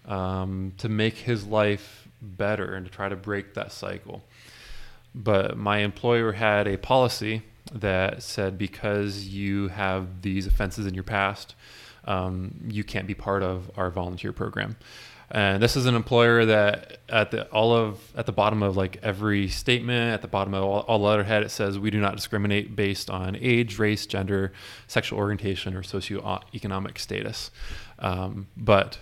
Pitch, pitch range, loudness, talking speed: 100 Hz, 95-110 Hz, -26 LUFS, 165 wpm